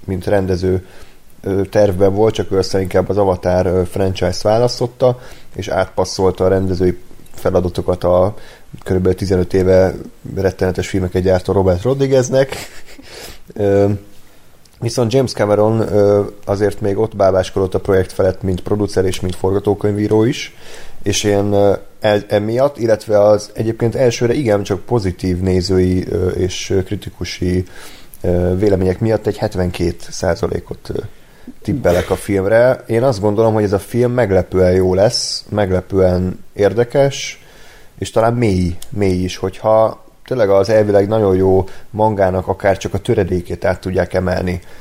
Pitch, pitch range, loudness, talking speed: 100 Hz, 95-110 Hz, -16 LUFS, 125 wpm